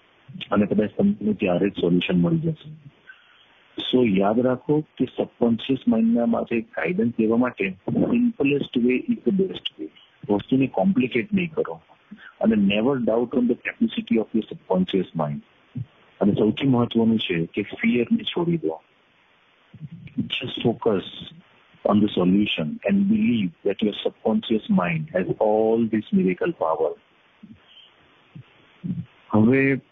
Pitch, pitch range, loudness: 125 Hz, 105-175 Hz, -23 LUFS